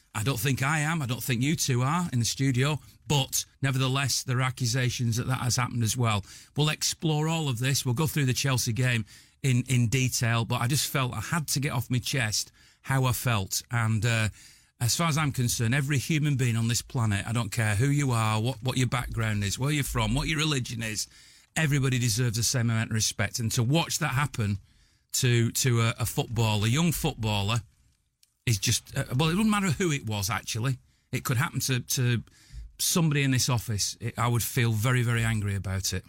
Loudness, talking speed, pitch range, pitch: -27 LUFS, 220 wpm, 115-135 Hz, 125 Hz